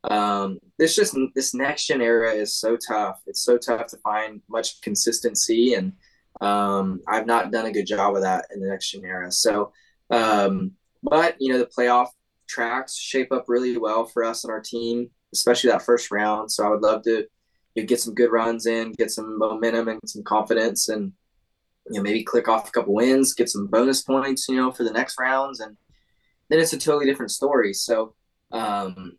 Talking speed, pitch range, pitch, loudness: 205 wpm, 105-125 Hz, 115 Hz, -22 LUFS